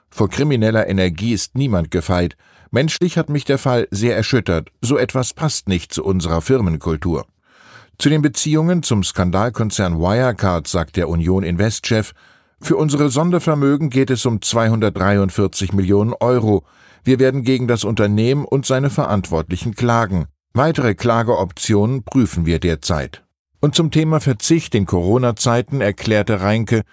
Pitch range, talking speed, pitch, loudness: 95-130 Hz, 135 wpm, 110 Hz, -17 LUFS